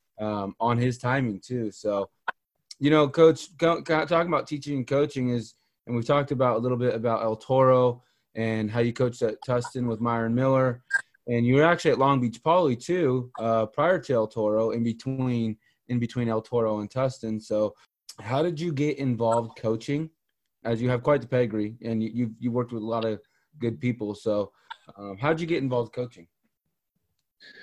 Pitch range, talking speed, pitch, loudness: 110-135 Hz, 195 wpm, 120 Hz, -26 LUFS